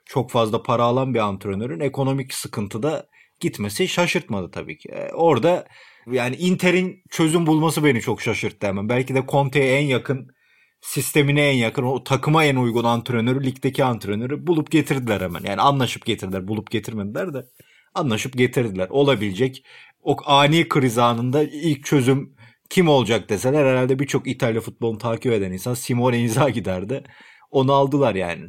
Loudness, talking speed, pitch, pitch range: -21 LUFS, 145 wpm, 130 Hz, 115-145 Hz